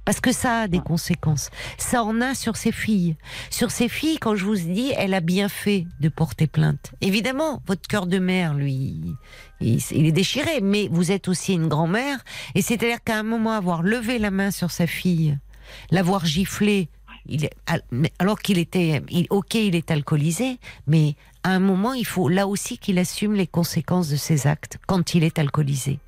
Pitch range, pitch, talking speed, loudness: 155-210 Hz, 185 Hz, 185 wpm, -22 LUFS